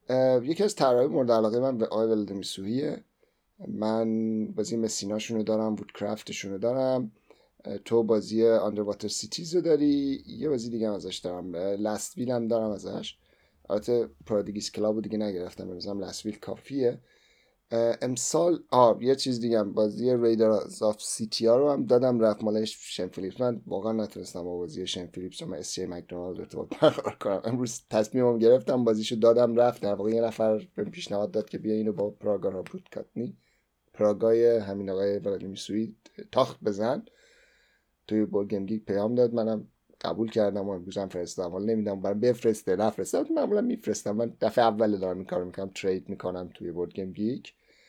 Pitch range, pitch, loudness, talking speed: 100-115 Hz, 110 Hz, -28 LUFS, 175 wpm